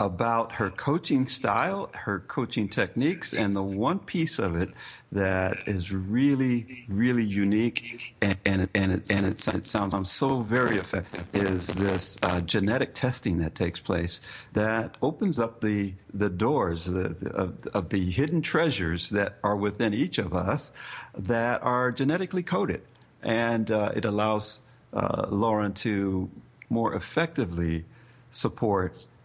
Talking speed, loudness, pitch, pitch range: 145 wpm, -26 LUFS, 105 Hz, 95-120 Hz